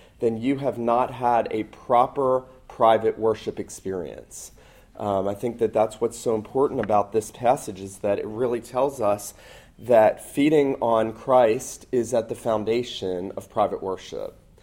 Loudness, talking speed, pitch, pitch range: -24 LUFS, 155 wpm, 115 Hz, 105-125 Hz